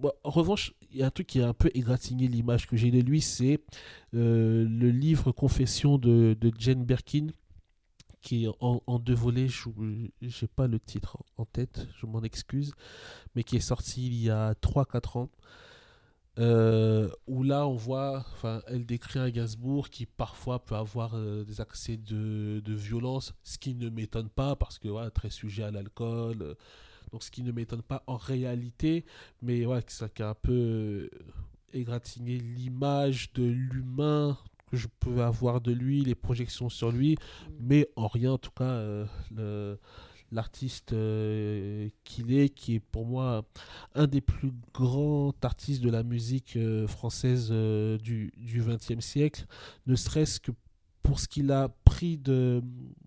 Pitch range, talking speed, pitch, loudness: 110-130 Hz, 170 wpm, 120 Hz, -30 LUFS